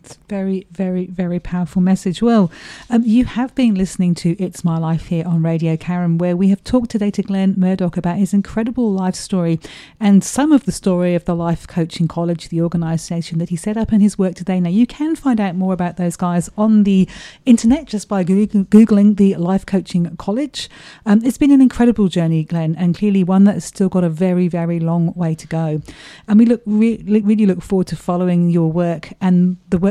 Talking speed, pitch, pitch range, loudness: 215 wpm, 185 Hz, 175-210 Hz, -16 LUFS